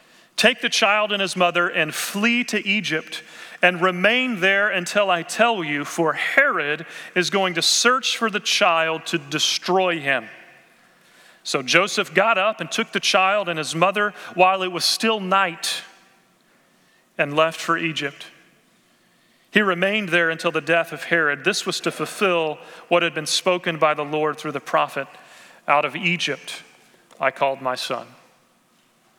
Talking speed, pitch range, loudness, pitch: 160 wpm, 160-195 Hz, -20 LUFS, 175 Hz